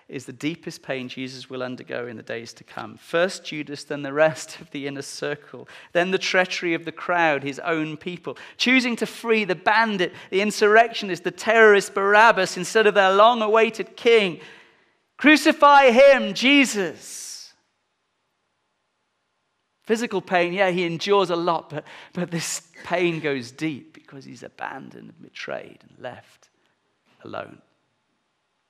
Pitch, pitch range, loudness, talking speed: 180 Hz, 155-215 Hz, -20 LUFS, 145 wpm